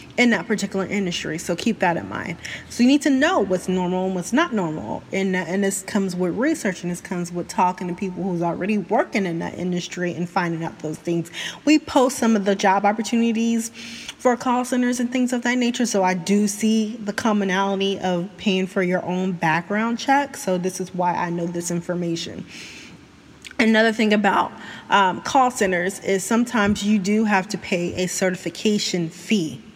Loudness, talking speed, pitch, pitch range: -22 LUFS, 195 wpm, 195 Hz, 180-225 Hz